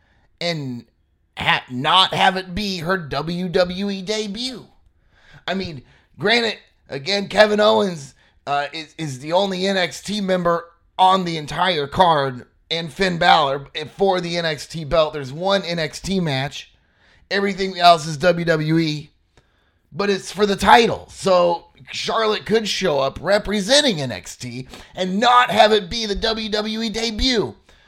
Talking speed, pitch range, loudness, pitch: 130 wpm, 150-200 Hz, -19 LUFS, 180 Hz